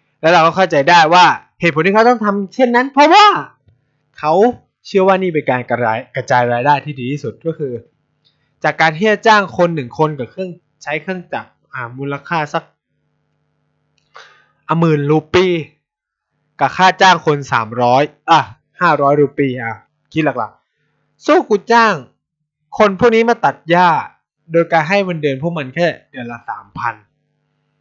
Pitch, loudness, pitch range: 155 Hz, -14 LUFS, 140-185 Hz